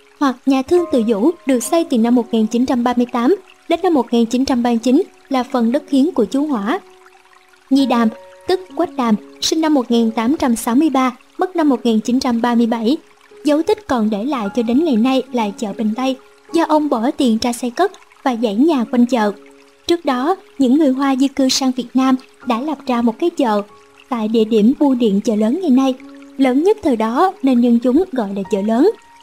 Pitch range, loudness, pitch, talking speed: 235-300 Hz, -16 LUFS, 260 Hz, 190 wpm